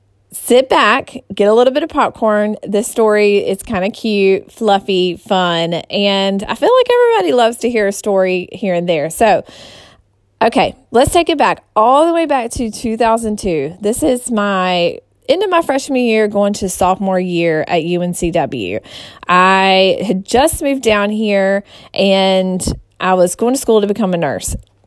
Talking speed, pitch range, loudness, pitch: 170 wpm, 185-235 Hz, -14 LUFS, 205 Hz